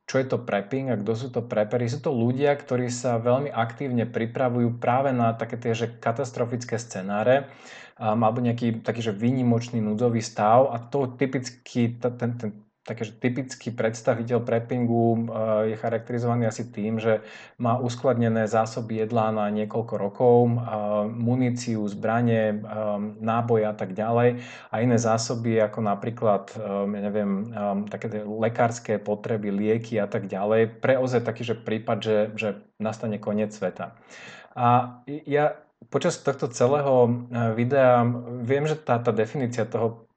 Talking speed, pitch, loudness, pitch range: 140 wpm, 115 Hz, -25 LUFS, 110-125 Hz